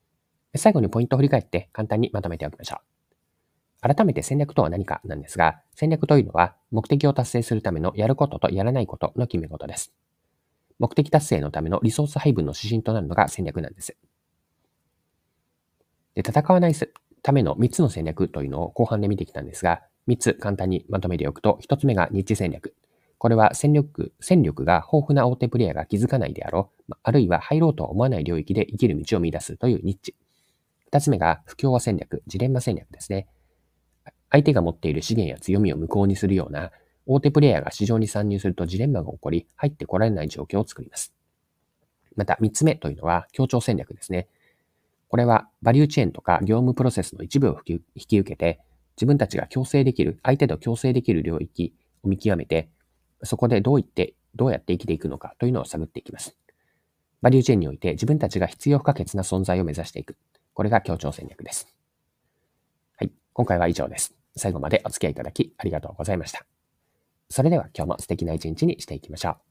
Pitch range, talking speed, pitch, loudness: 85-125 Hz, 415 characters per minute, 100 Hz, -23 LUFS